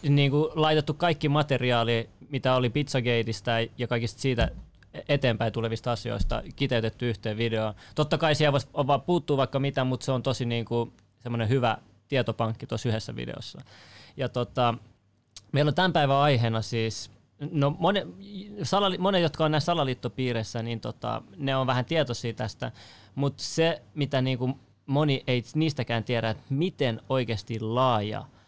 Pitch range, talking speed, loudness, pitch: 115-145 Hz, 155 wpm, -27 LUFS, 125 Hz